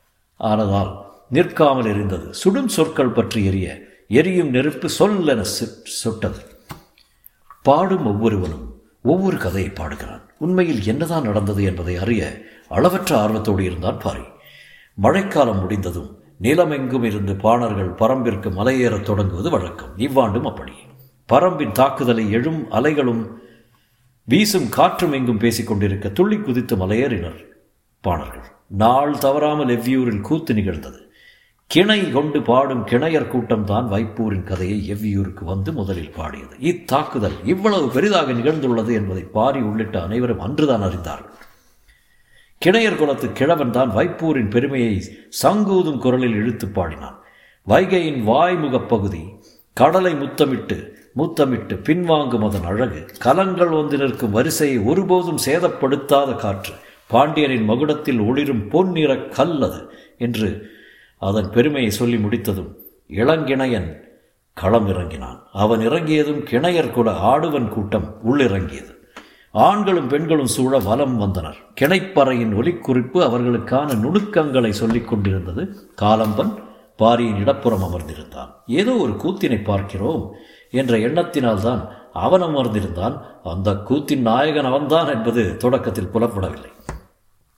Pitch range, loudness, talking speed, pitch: 105-140 Hz, -19 LUFS, 105 wpm, 115 Hz